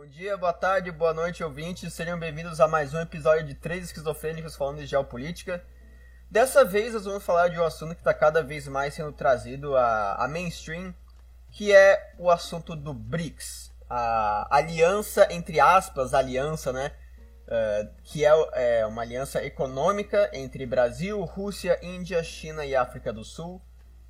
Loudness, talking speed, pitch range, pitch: -25 LUFS, 160 wpm, 130-175 Hz, 160 Hz